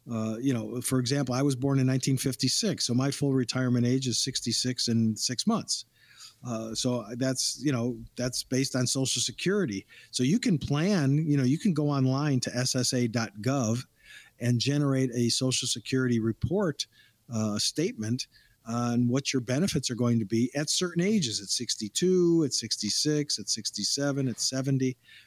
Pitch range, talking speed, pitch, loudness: 120-140 Hz, 165 wpm, 130 Hz, -28 LUFS